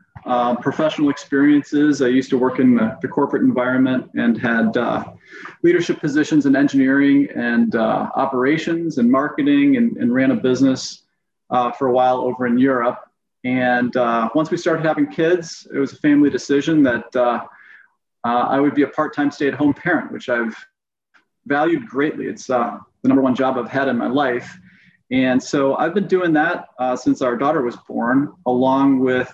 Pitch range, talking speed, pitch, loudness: 125-170 Hz, 185 wpm, 140 Hz, -18 LUFS